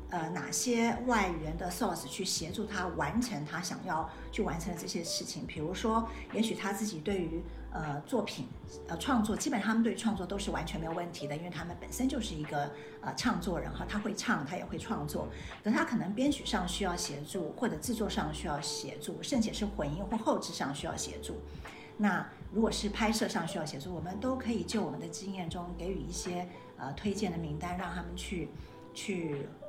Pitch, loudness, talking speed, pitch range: 190 Hz, -35 LUFS, 315 characters per minute, 160-220 Hz